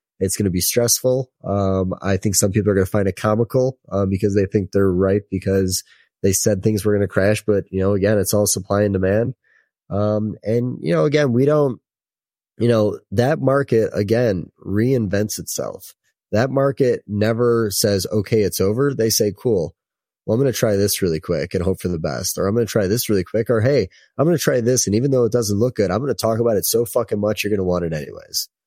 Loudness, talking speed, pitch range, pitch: -19 LUFS, 220 wpm, 95-120 Hz, 105 Hz